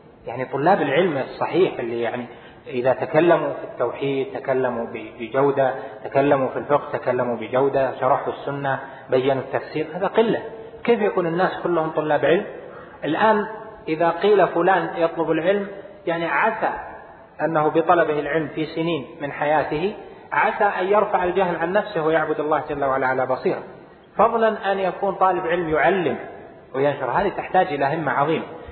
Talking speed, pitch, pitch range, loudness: 140 wpm, 160 Hz, 140-190 Hz, -21 LUFS